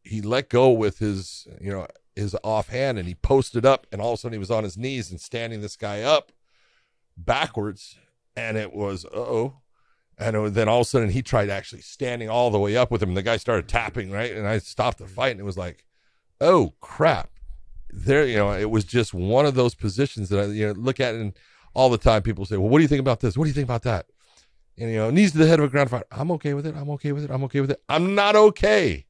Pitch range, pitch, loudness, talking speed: 105-130 Hz, 115 Hz, -23 LUFS, 265 wpm